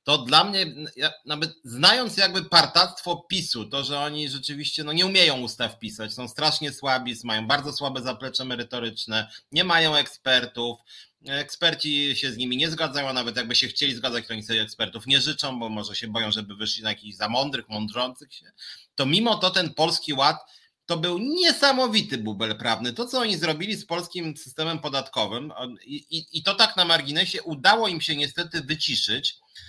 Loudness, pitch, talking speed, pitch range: -23 LUFS, 145 Hz, 180 wpm, 120-165 Hz